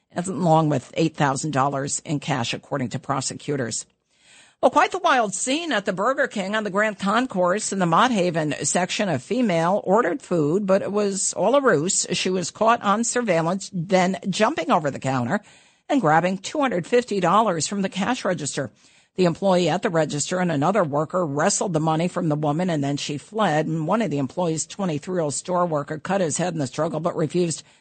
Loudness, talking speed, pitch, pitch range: -22 LUFS, 205 wpm, 175 Hz, 150-200 Hz